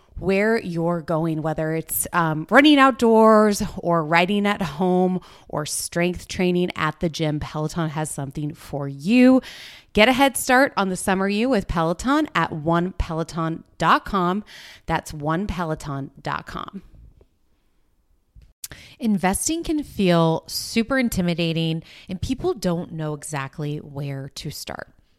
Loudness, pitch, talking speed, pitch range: -21 LUFS, 175 Hz, 120 wpm, 155-210 Hz